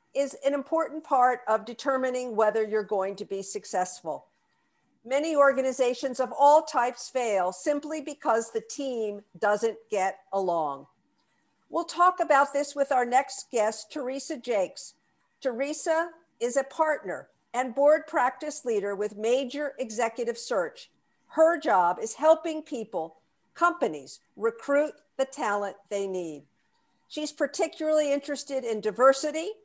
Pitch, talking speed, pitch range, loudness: 260 Hz, 130 wpm, 220-300 Hz, -27 LUFS